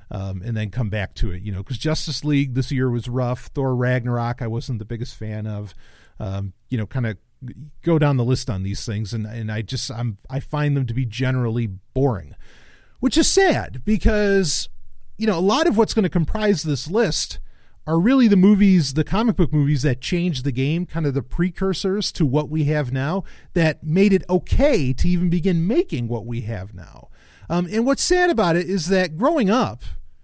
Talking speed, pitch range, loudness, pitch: 210 wpm, 115-180 Hz, -21 LUFS, 140 Hz